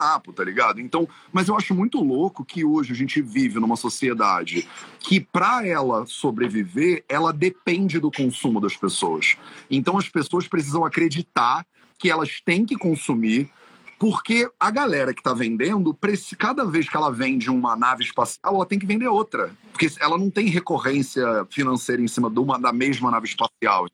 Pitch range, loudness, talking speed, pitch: 135-205 Hz, -22 LUFS, 175 wpm, 165 Hz